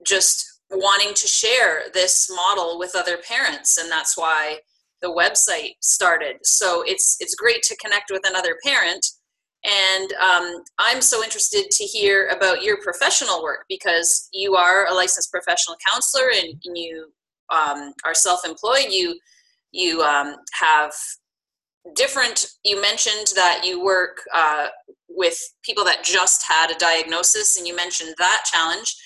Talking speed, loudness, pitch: 145 wpm, -18 LUFS, 190 Hz